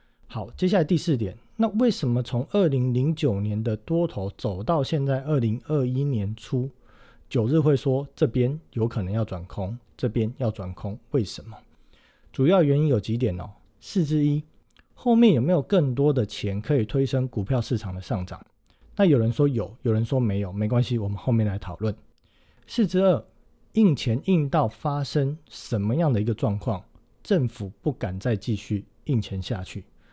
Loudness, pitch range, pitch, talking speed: -25 LUFS, 110-150 Hz, 125 Hz, 255 characters per minute